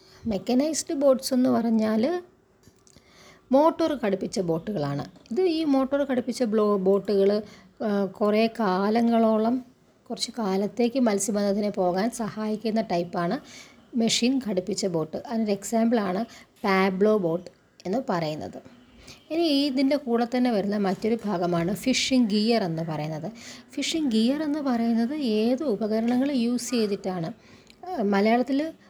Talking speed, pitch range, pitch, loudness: 105 wpm, 200-255 Hz, 225 Hz, -25 LUFS